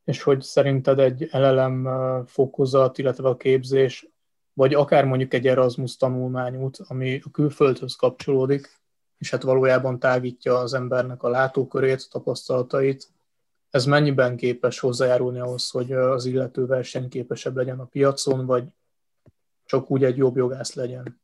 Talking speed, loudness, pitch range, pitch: 135 wpm, -22 LUFS, 125-135 Hz, 130 Hz